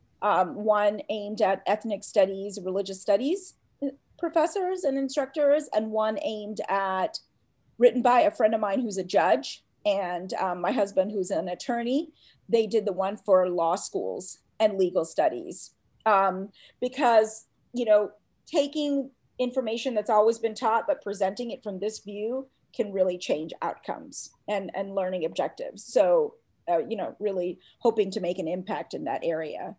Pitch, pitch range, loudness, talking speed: 215 Hz, 195-255 Hz, -27 LUFS, 155 wpm